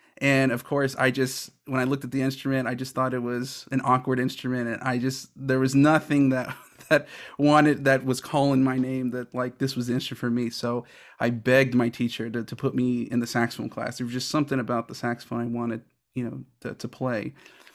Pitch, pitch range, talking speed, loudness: 130 Hz, 120-135 Hz, 230 wpm, -25 LUFS